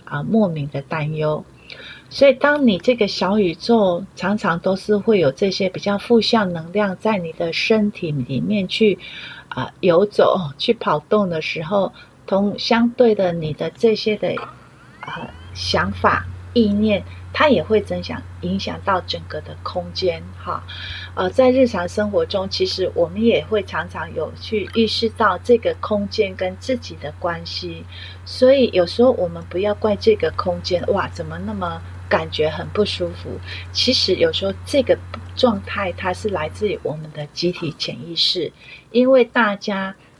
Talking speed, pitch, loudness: 235 characters per minute, 185 Hz, -19 LUFS